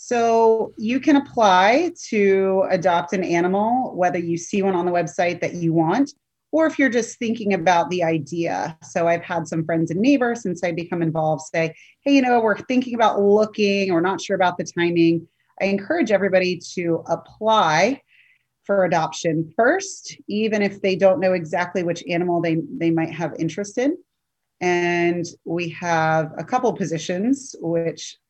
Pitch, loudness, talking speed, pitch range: 185 Hz, -20 LUFS, 170 wpm, 170-220 Hz